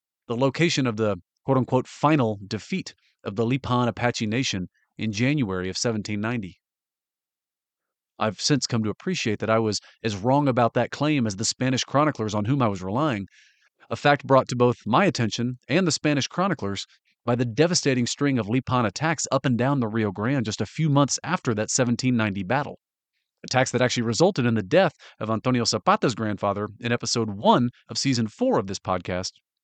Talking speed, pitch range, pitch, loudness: 185 wpm, 110-135 Hz, 120 Hz, -24 LUFS